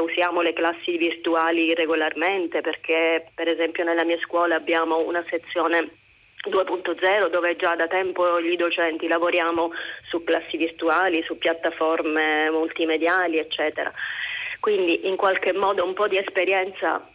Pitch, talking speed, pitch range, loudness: 170 Hz, 130 wpm, 165-175 Hz, -23 LUFS